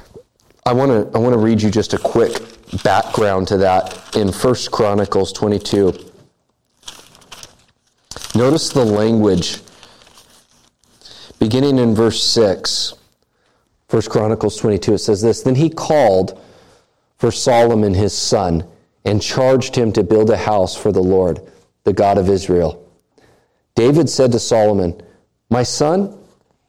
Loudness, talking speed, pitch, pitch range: -15 LUFS, 130 wpm, 105 Hz, 95-115 Hz